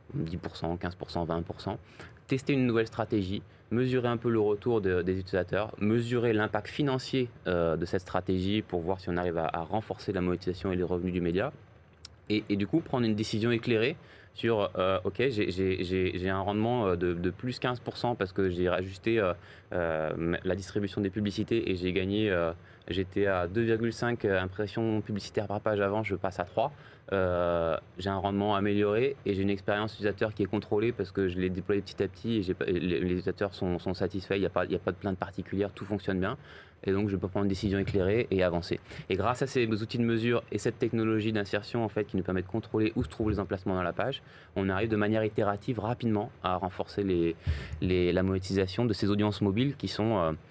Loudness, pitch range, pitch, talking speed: -30 LUFS, 90-110 Hz, 100 Hz, 210 wpm